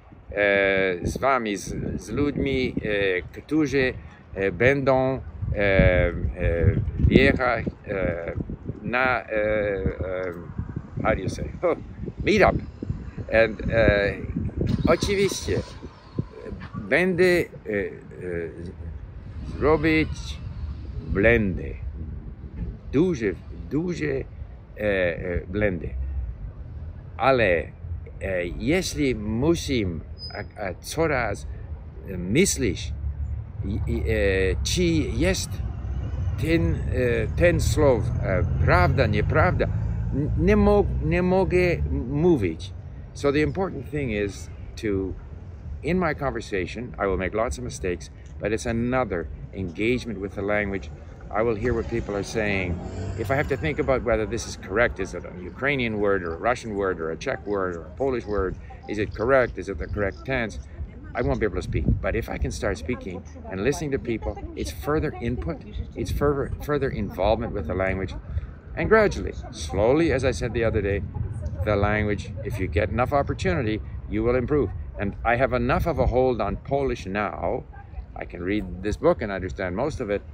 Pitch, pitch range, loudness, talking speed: 100 Hz, 90-120 Hz, -25 LUFS, 120 wpm